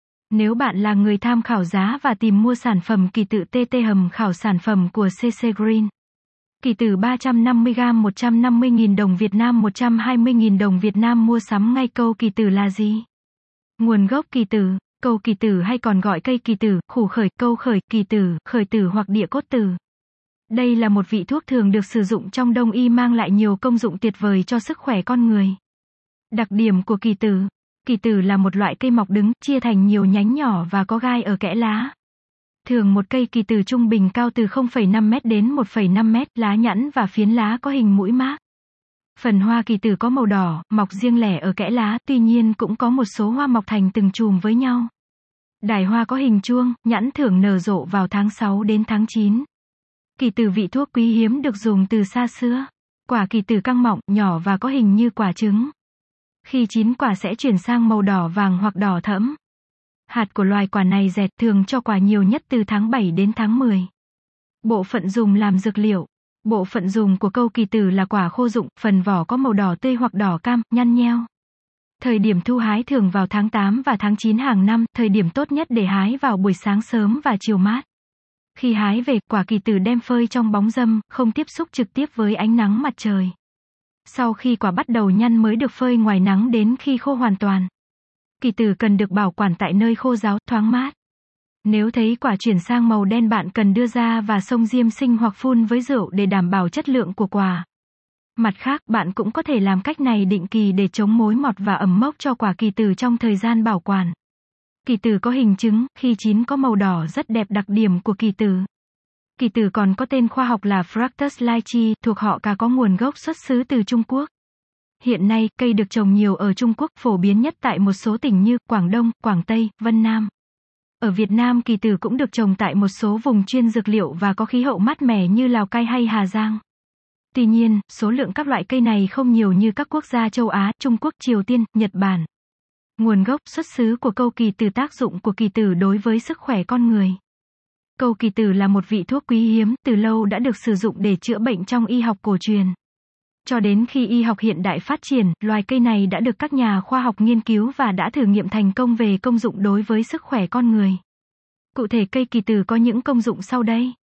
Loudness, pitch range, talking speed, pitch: -19 LUFS, 205-240 Hz, 225 wpm, 225 Hz